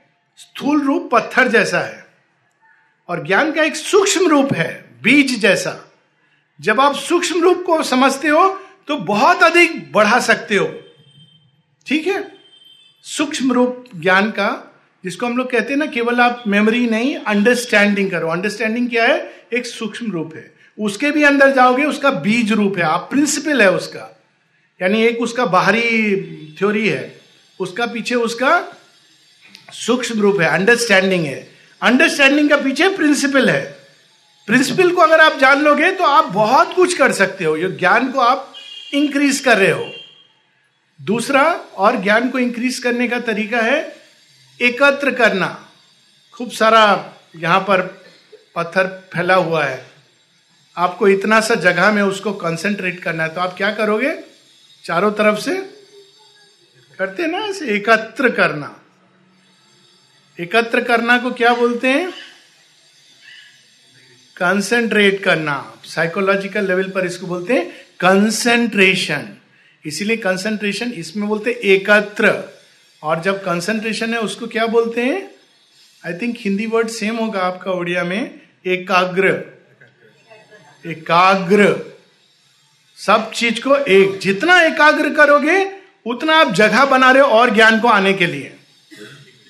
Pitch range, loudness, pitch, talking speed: 185-275 Hz, -15 LUFS, 220 Hz, 135 wpm